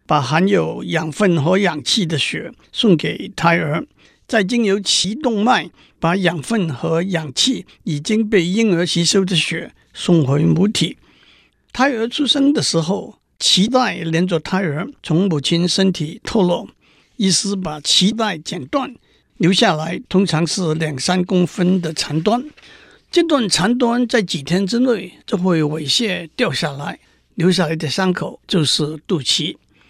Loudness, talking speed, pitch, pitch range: -17 LUFS, 210 characters per minute, 180 Hz, 165-210 Hz